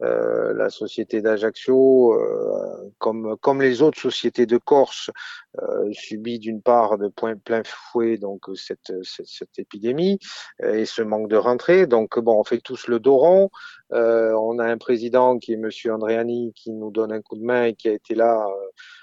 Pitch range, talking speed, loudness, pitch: 110-155 Hz, 185 wpm, -21 LUFS, 120 Hz